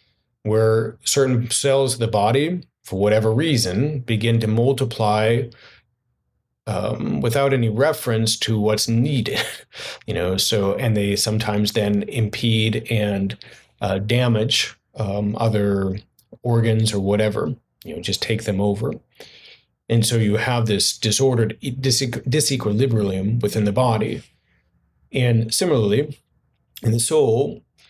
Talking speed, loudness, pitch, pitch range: 125 wpm, -20 LUFS, 110 Hz, 105-120 Hz